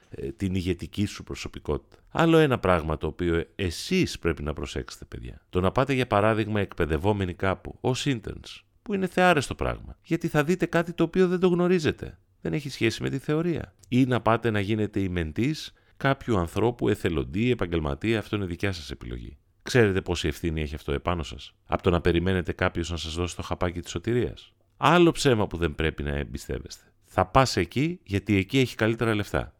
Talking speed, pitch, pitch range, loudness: 185 wpm, 100 Hz, 85-130 Hz, -26 LUFS